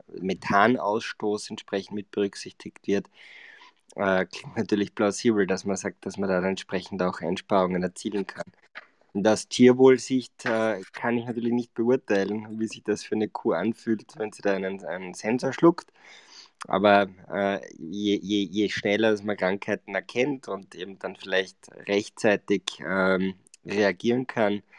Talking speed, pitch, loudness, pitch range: 145 wpm, 105 Hz, -26 LUFS, 95-115 Hz